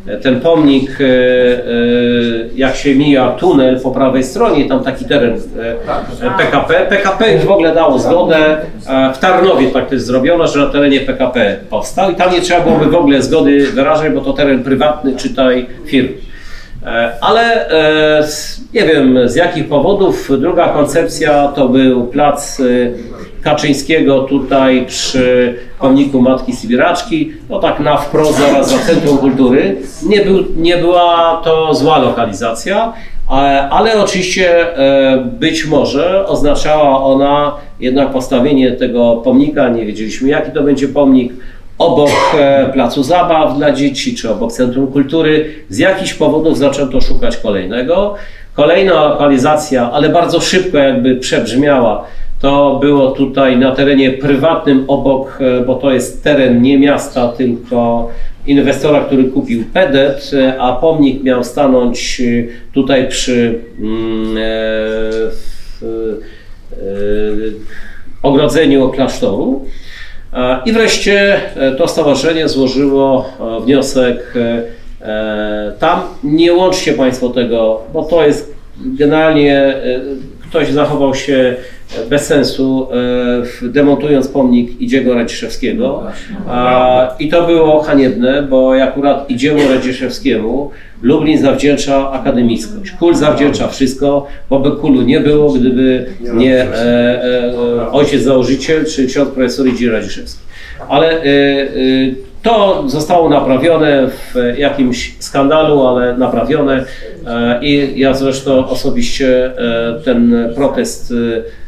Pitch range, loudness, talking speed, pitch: 125-150 Hz, -11 LUFS, 115 wpm, 135 Hz